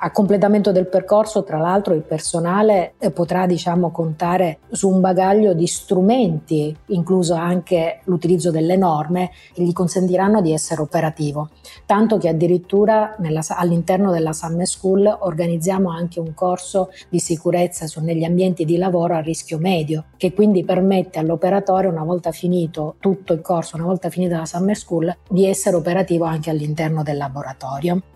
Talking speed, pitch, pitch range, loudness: 155 wpm, 175 Hz, 165-190 Hz, -18 LUFS